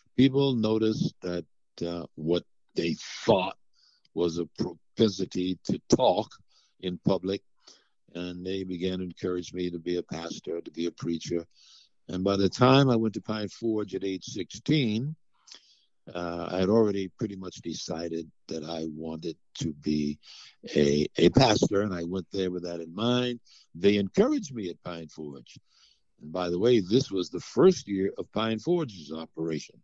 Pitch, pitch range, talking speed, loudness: 90 Hz, 85-110 Hz, 165 wpm, -28 LUFS